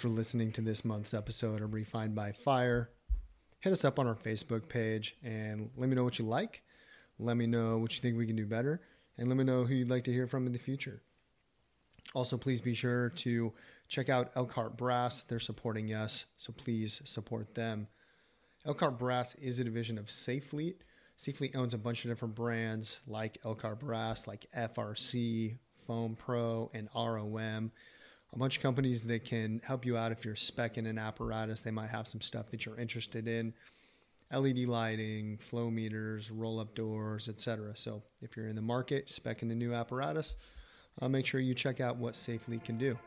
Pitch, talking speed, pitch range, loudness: 115 Hz, 190 wpm, 110-125 Hz, -37 LUFS